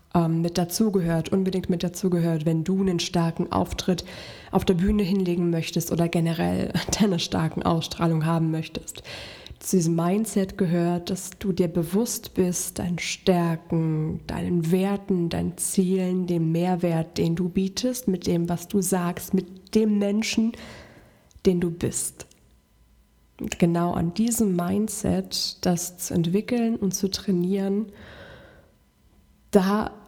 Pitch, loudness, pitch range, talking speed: 180 Hz, -25 LUFS, 170-195 Hz, 130 wpm